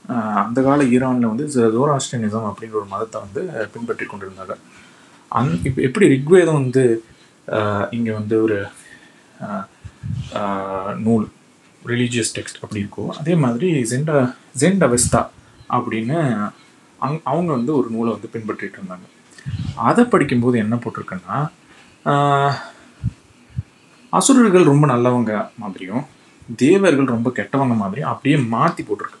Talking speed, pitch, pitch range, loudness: 110 wpm, 120 Hz, 110-140 Hz, -18 LUFS